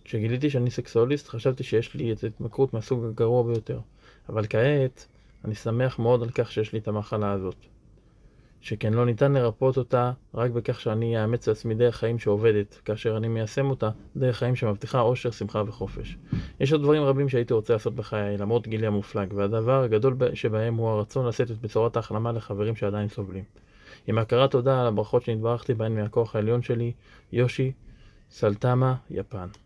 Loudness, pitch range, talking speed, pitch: -26 LUFS, 110-125 Hz, 165 wpm, 115 Hz